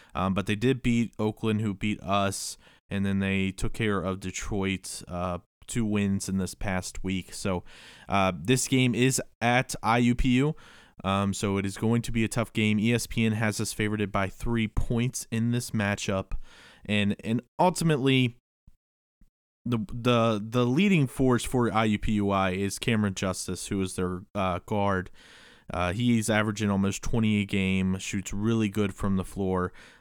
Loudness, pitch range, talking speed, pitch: -27 LUFS, 95-115 Hz, 160 wpm, 105 Hz